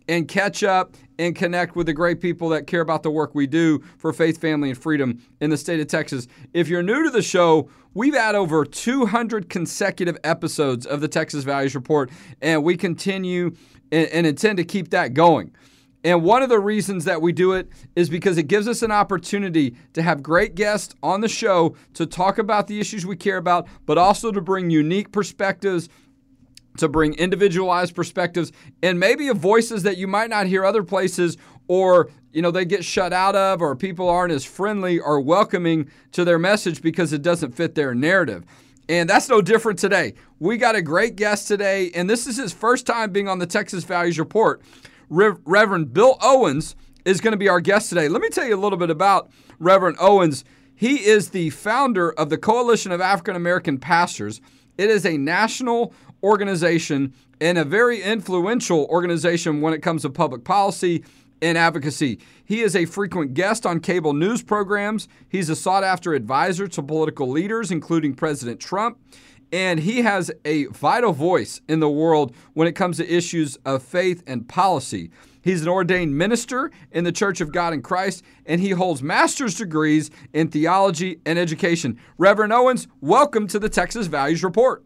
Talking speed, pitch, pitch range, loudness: 190 wpm, 175 Hz, 155-200 Hz, -20 LUFS